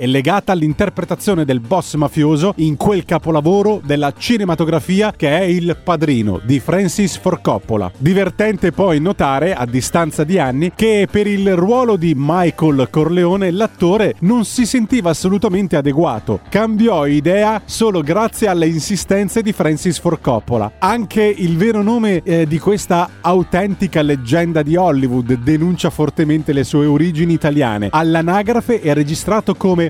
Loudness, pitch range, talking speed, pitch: -15 LUFS, 155-200 Hz, 135 wpm, 175 Hz